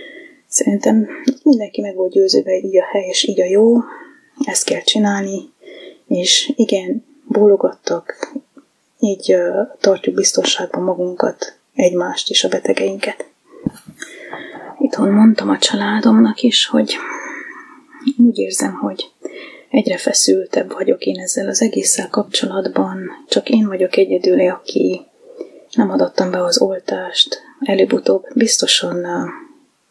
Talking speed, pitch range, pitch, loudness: 110 wpm, 200-290 Hz, 235 Hz, -15 LUFS